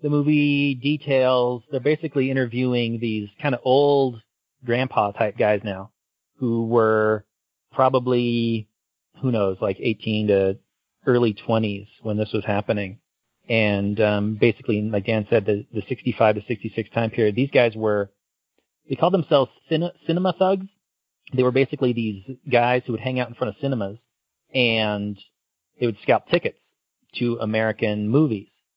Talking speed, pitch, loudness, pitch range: 150 wpm, 115 Hz, -22 LUFS, 105-130 Hz